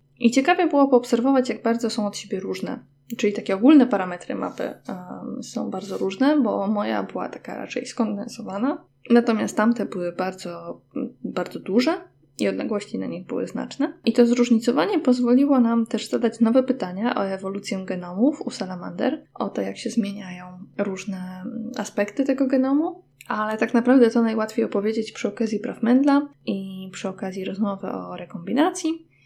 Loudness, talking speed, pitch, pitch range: -23 LUFS, 155 wpm, 230 Hz, 200-255 Hz